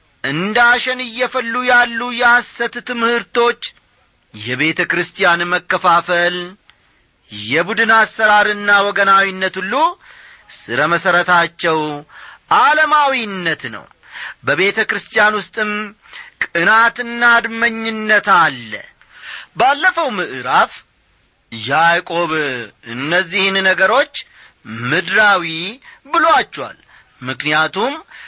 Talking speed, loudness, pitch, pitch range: 65 wpm, -14 LUFS, 200 Hz, 170-235 Hz